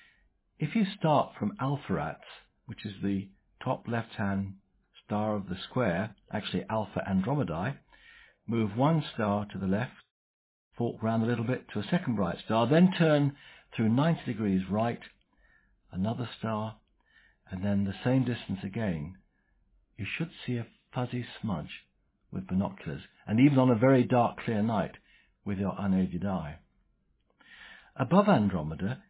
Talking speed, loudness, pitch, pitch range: 145 wpm, -30 LUFS, 110 Hz, 100-130 Hz